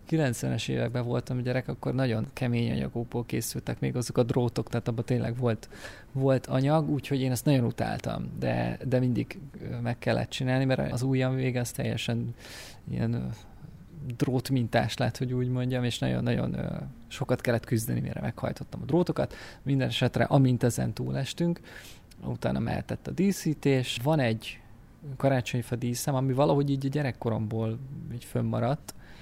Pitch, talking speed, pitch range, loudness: 125 Hz, 150 wpm, 115-135 Hz, -29 LUFS